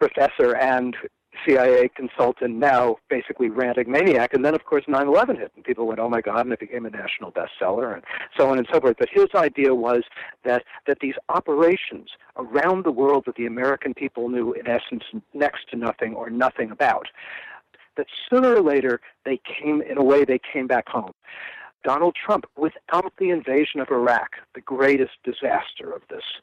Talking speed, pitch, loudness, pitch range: 185 wpm, 135 Hz, -22 LUFS, 125-175 Hz